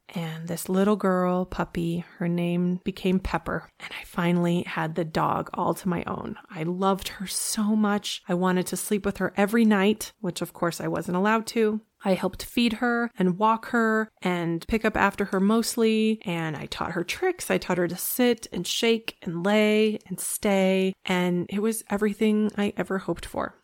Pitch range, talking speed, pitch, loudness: 180-215 Hz, 195 wpm, 190 Hz, -26 LUFS